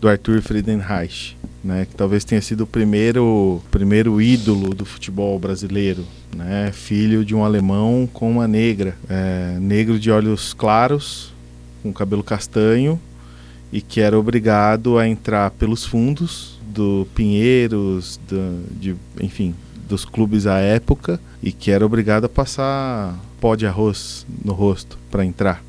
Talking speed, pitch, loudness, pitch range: 140 wpm, 105 Hz, -18 LUFS, 95-110 Hz